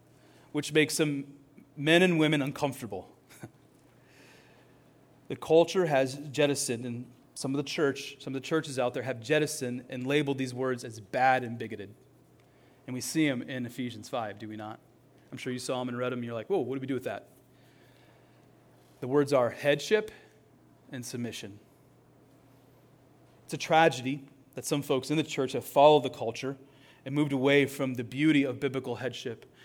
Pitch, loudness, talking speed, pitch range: 135 Hz, -29 LUFS, 180 wpm, 125-145 Hz